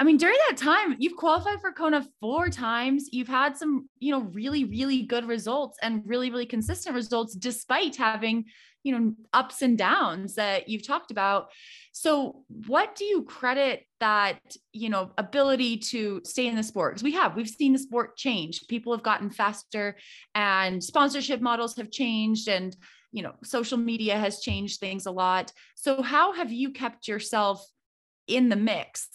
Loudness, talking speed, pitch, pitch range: -27 LUFS, 175 wpm, 240 Hz, 215-275 Hz